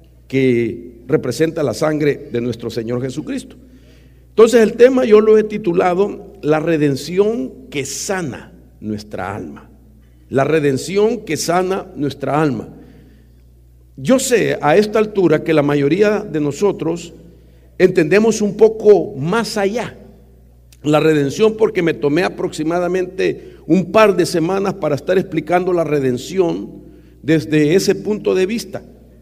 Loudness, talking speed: -16 LUFS, 125 wpm